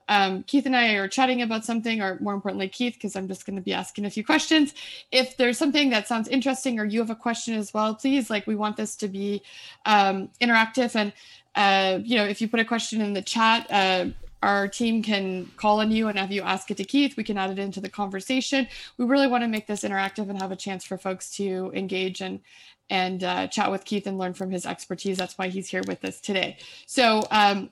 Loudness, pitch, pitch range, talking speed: -25 LUFS, 210 Hz, 195-235 Hz, 245 wpm